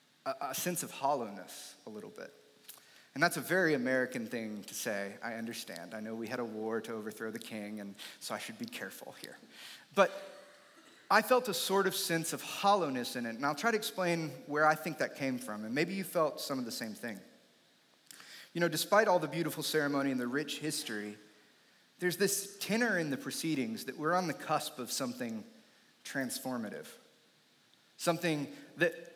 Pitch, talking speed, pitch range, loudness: 155 Hz, 190 wpm, 120-180 Hz, -34 LUFS